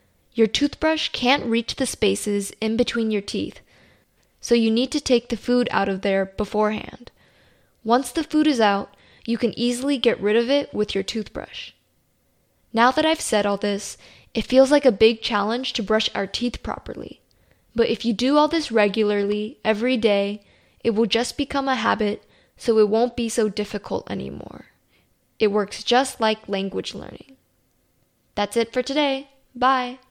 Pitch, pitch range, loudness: 230 Hz, 210-255 Hz, -22 LUFS